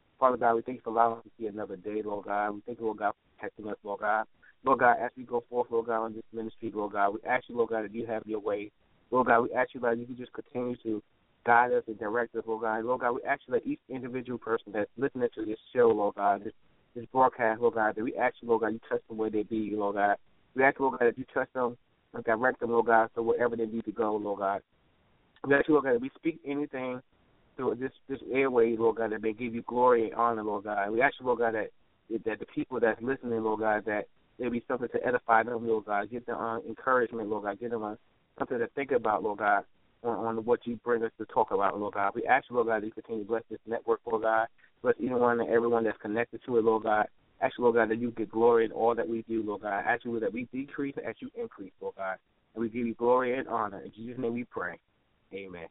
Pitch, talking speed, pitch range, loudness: 115 Hz, 275 wpm, 110-125 Hz, -30 LUFS